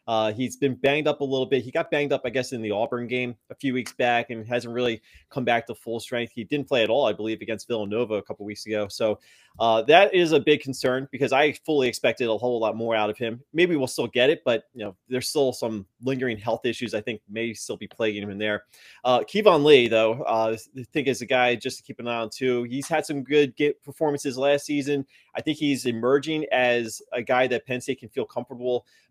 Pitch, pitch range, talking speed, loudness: 125 Hz, 115-140 Hz, 255 wpm, -24 LUFS